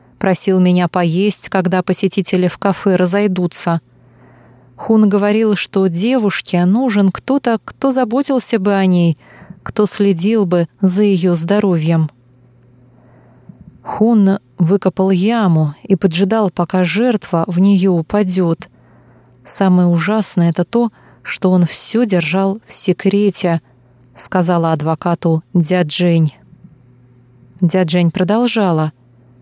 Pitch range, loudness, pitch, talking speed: 165-200 Hz, -15 LUFS, 180 Hz, 100 wpm